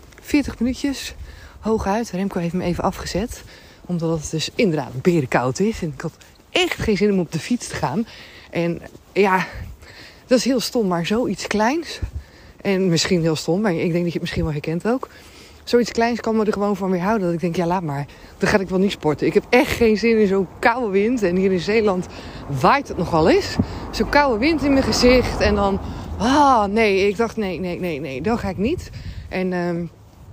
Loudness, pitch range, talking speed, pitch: -20 LUFS, 170-225 Hz, 220 wpm, 195 Hz